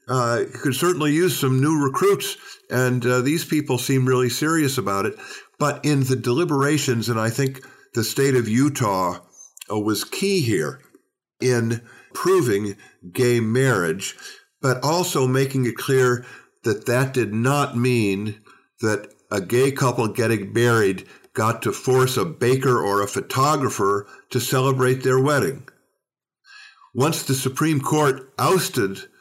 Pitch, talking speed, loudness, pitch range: 130 Hz, 140 wpm, -21 LUFS, 120-145 Hz